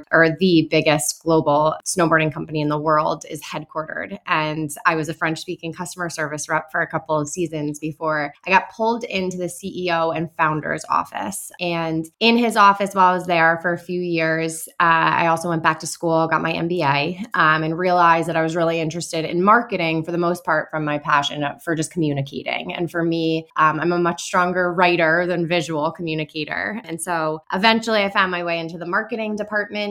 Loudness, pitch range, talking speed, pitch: -20 LUFS, 155-180 Hz, 200 wpm, 165 Hz